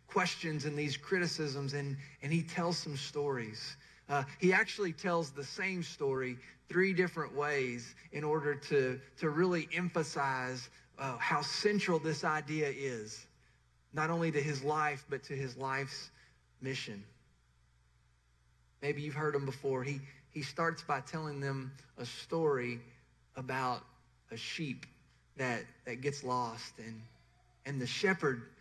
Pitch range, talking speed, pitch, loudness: 125-155 Hz, 140 wpm, 140 Hz, -36 LUFS